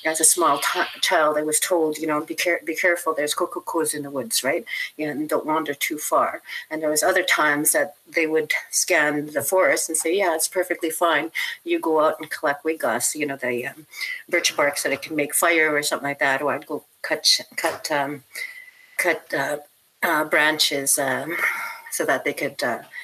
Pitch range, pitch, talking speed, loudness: 145-170 Hz, 155 Hz, 220 wpm, -22 LUFS